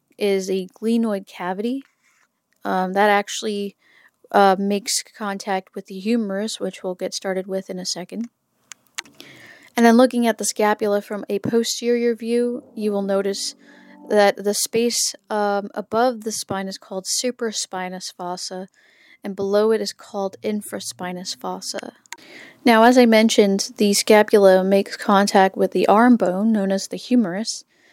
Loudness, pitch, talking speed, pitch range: -20 LUFS, 205 Hz, 145 wpm, 195-230 Hz